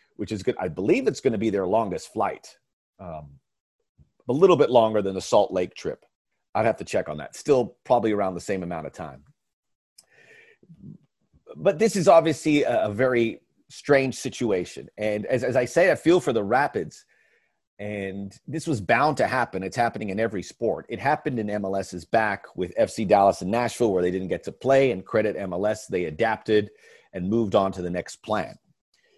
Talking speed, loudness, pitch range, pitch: 190 wpm, -24 LUFS, 95-145 Hz, 115 Hz